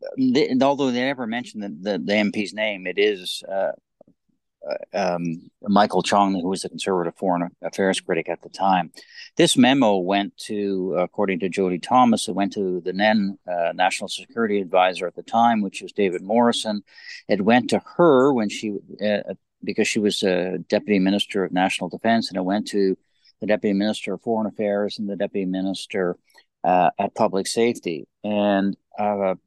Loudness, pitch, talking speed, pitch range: -22 LUFS, 100 Hz, 175 wpm, 95-110 Hz